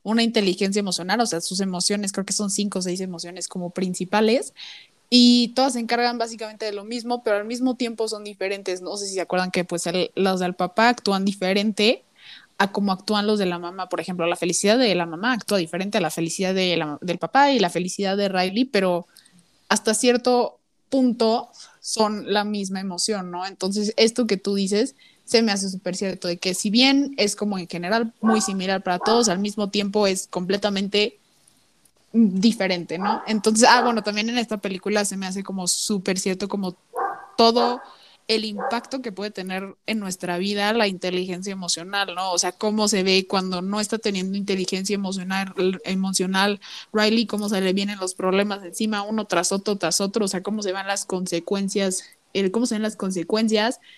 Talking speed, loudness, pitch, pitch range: 190 wpm, -22 LUFS, 200 Hz, 185-220 Hz